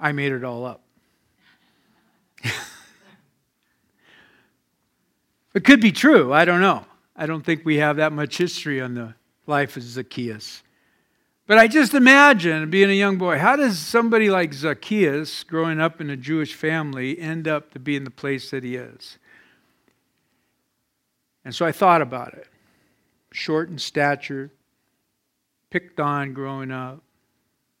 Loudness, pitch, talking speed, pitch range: -19 LUFS, 155 Hz, 145 wpm, 135-180 Hz